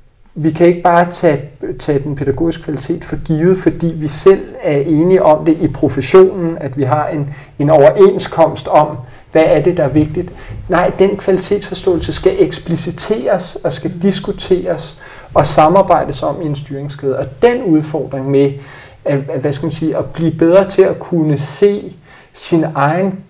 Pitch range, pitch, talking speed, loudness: 145-180 Hz, 160 Hz, 160 wpm, -13 LUFS